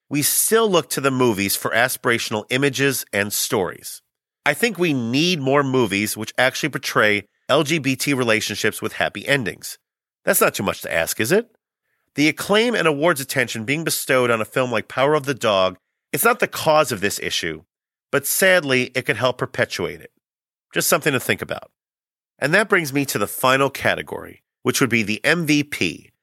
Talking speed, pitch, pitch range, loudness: 185 wpm, 135 Hz, 115-155 Hz, -19 LUFS